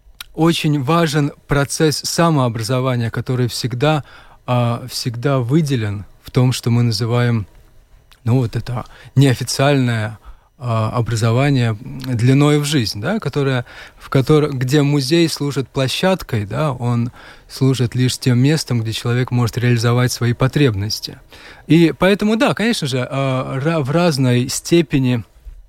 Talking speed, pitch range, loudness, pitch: 115 wpm, 120-145 Hz, -17 LUFS, 130 Hz